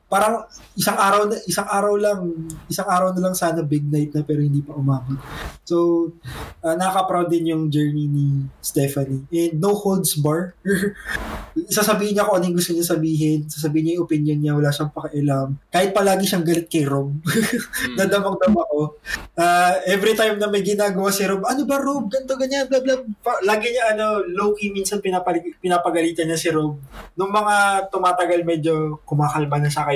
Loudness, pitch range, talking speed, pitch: -20 LUFS, 155-200 Hz, 175 wpm, 175 Hz